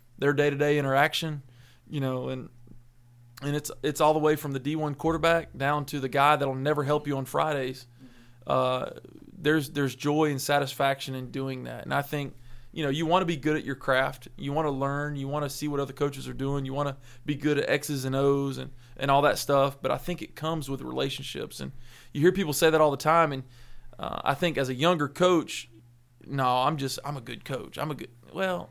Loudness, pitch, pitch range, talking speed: -27 LUFS, 140 Hz, 130-150 Hz, 230 wpm